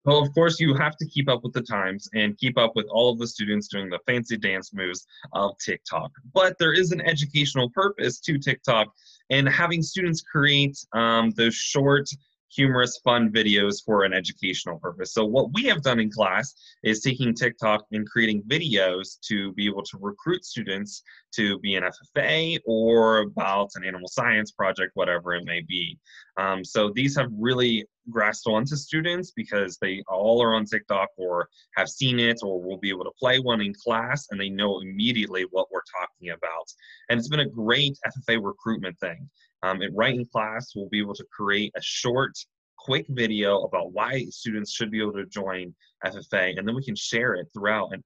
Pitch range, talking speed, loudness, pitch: 100-135 Hz, 190 wpm, -24 LUFS, 115 Hz